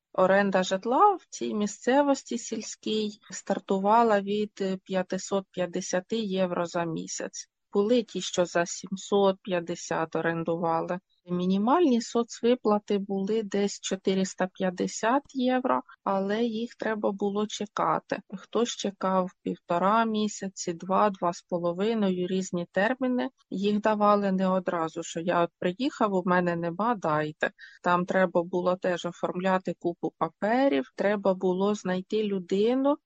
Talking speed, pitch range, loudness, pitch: 110 wpm, 180-220 Hz, -27 LUFS, 195 Hz